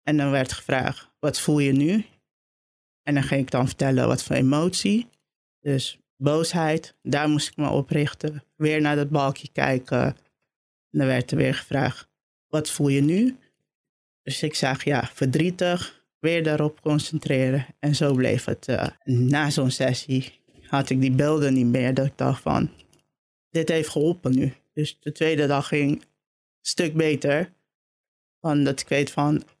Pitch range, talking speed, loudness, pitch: 135-155 Hz, 170 wpm, -24 LUFS, 145 Hz